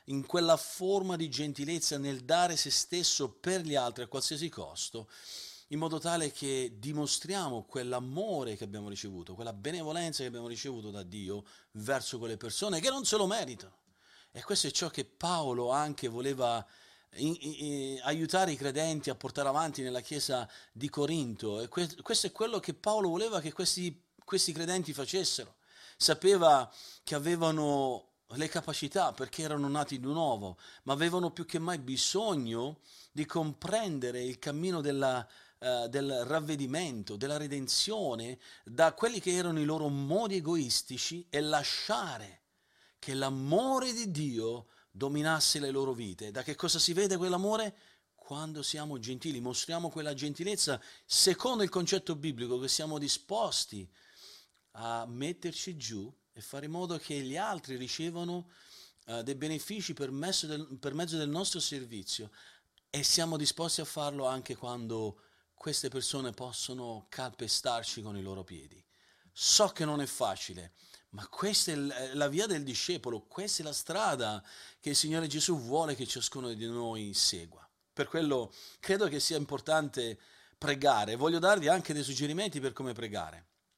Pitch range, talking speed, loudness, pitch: 125-170 Hz, 155 wpm, -33 LUFS, 145 Hz